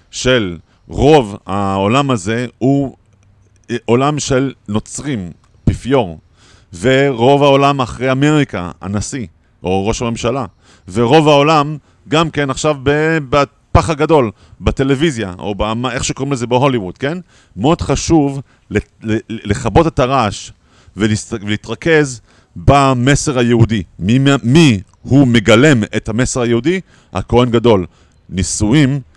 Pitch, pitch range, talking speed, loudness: 120 Hz, 105-140 Hz, 105 wpm, -14 LUFS